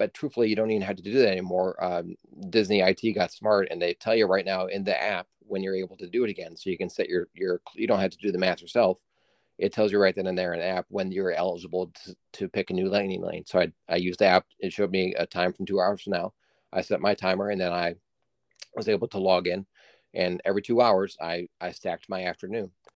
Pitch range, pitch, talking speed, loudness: 90-105 Hz, 95 Hz, 265 wpm, -27 LUFS